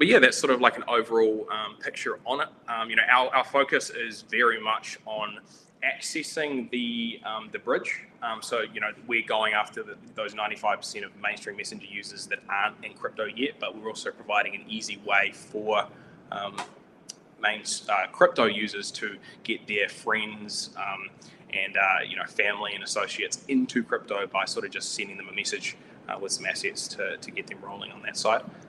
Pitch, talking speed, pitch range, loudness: 115 Hz, 195 wpm, 110-160 Hz, -27 LUFS